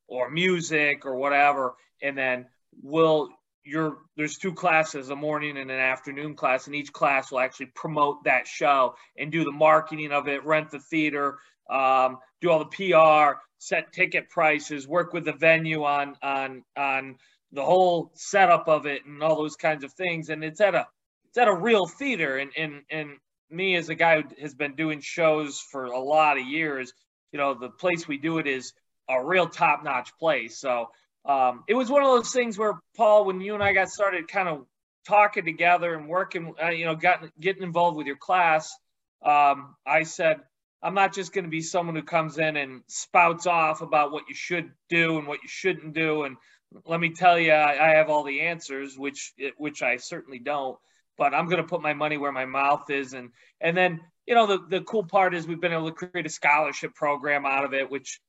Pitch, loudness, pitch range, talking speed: 155 Hz, -24 LUFS, 140-175 Hz, 210 wpm